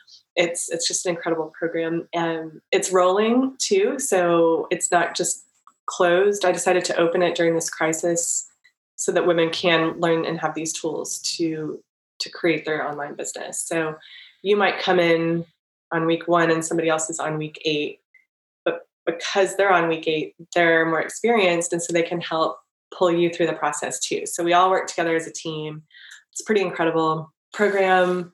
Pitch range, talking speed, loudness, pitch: 165-180 Hz, 180 wpm, -22 LUFS, 170 Hz